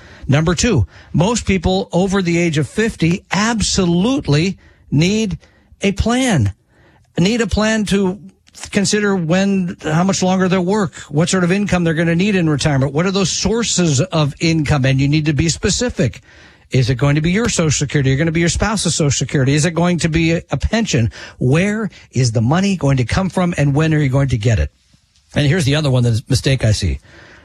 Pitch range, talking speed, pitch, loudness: 135-190 Hz, 210 wpm, 165 Hz, -16 LUFS